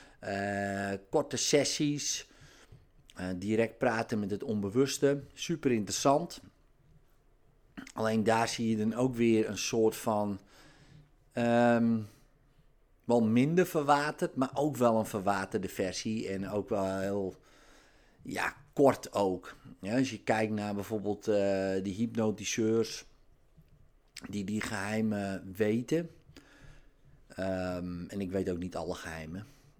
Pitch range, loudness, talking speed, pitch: 100-130 Hz, -31 LUFS, 120 wpm, 110 Hz